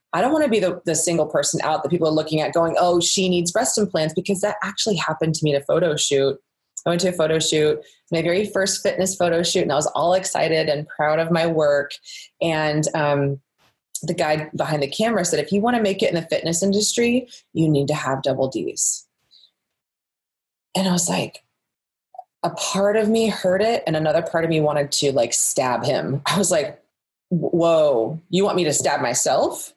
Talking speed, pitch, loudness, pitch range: 215 wpm, 165 Hz, -20 LUFS, 155-195 Hz